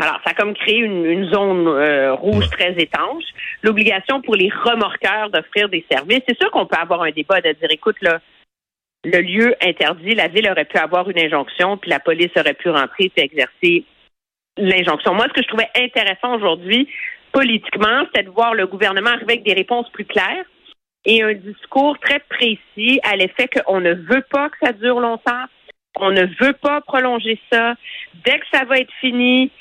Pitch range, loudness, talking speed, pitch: 185-255 Hz, -16 LUFS, 195 wpm, 220 Hz